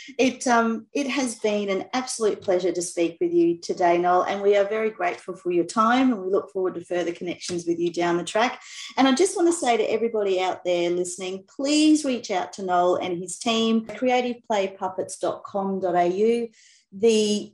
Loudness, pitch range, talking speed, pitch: -23 LUFS, 180-235 Hz, 190 wpm, 200 Hz